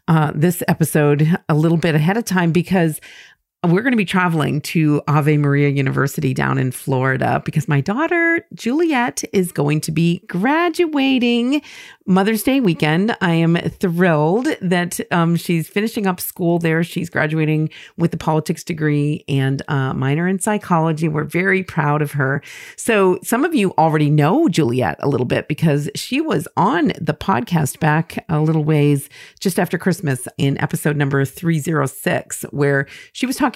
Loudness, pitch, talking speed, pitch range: -18 LUFS, 165 Hz, 165 wpm, 150-190 Hz